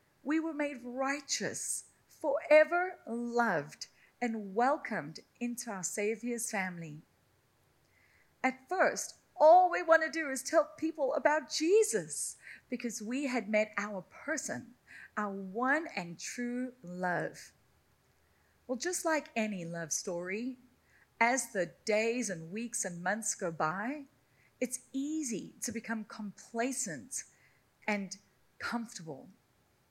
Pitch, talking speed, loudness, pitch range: 240 Hz, 115 wpm, -33 LUFS, 200-285 Hz